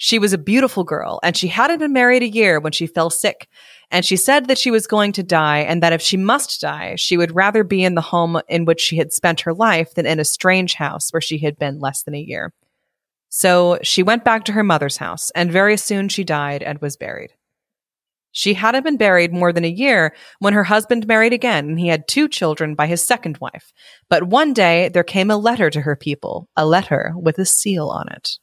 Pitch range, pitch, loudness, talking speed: 160-215 Hz, 180 Hz, -16 LUFS, 240 wpm